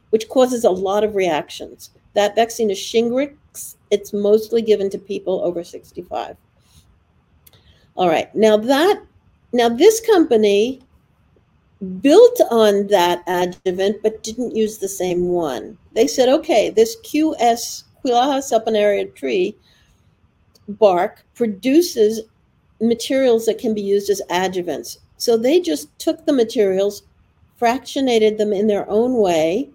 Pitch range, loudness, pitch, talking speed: 195-245 Hz, -18 LUFS, 220 Hz, 125 wpm